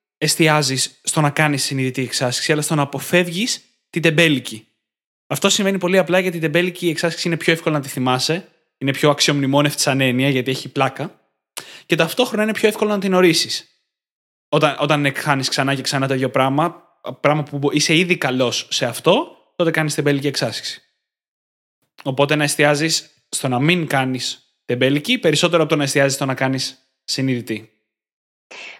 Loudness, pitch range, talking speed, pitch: -18 LUFS, 135-165 Hz, 165 wpm, 145 Hz